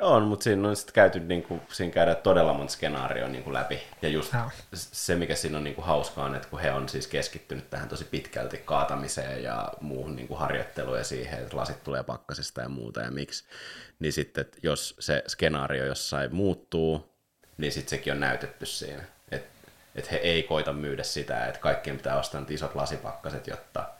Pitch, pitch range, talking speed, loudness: 75 Hz, 70-90 Hz, 180 wpm, -30 LUFS